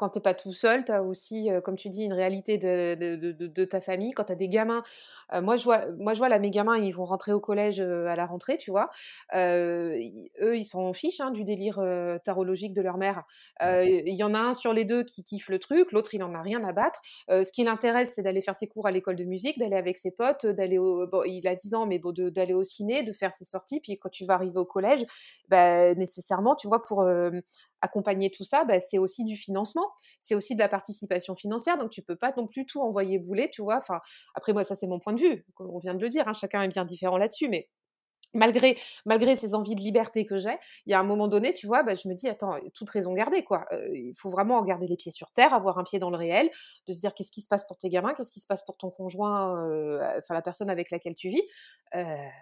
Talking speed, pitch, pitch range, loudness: 275 wpm, 195 Hz, 185-225 Hz, -28 LUFS